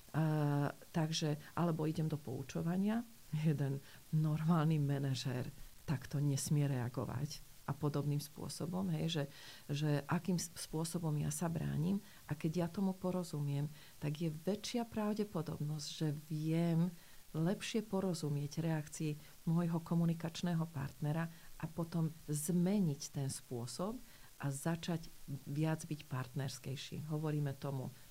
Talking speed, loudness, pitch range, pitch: 110 wpm, -39 LUFS, 145-170 Hz, 155 Hz